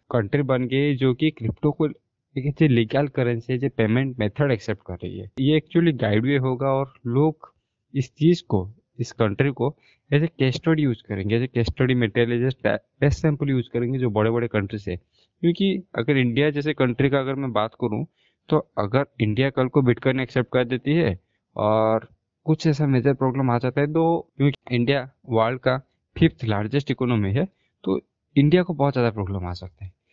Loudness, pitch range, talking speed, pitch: -23 LUFS, 115-145 Hz, 195 wpm, 130 Hz